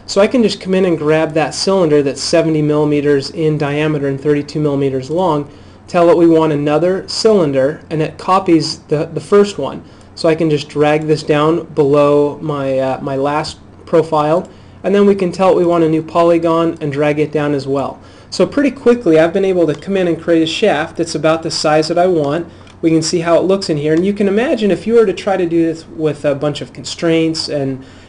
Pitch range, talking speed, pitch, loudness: 150-175 Hz, 230 wpm, 160 Hz, -14 LUFS